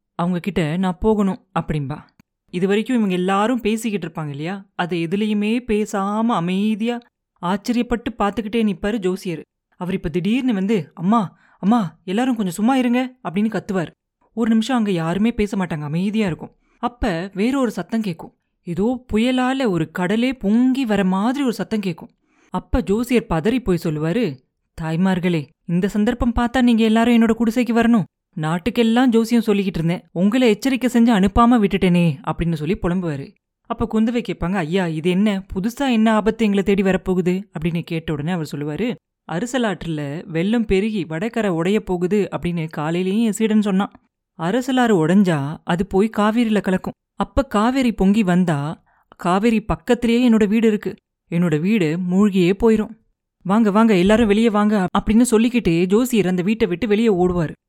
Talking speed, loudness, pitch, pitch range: 145 wpm, -19 LUFS, 205 Hz, 180-230 Hz